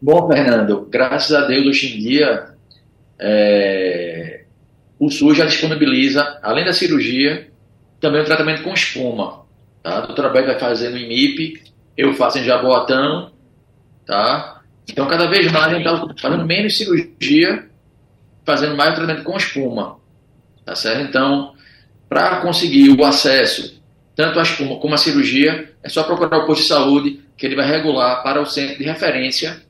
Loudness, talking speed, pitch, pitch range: -15 LUFS, 155 wpm, 145 Hz, 130-160 Hz